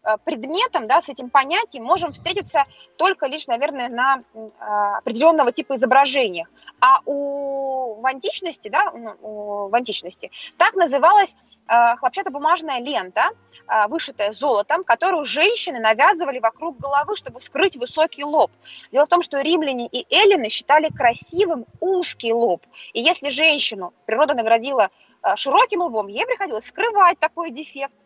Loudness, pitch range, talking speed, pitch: -19 LUFS, 240-345 Hz, 135 wpm, 285 Hz